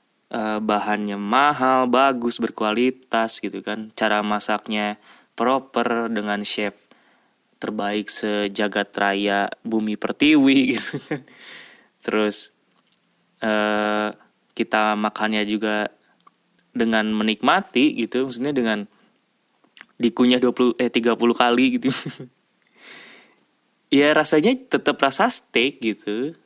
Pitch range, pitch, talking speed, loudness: 105-130 Hz, 110 Hz, 90 wpm, -20 LUFS